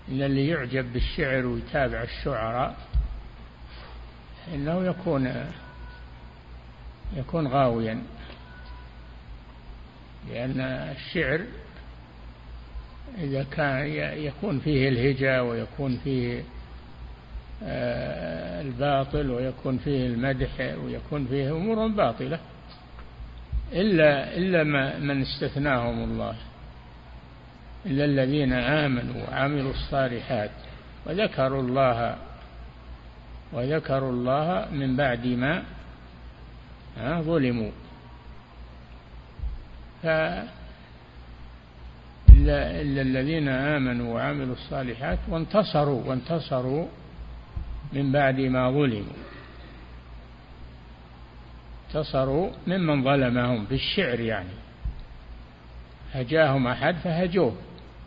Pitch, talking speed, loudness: 125 Hz, 70 wpm, -26 LUFS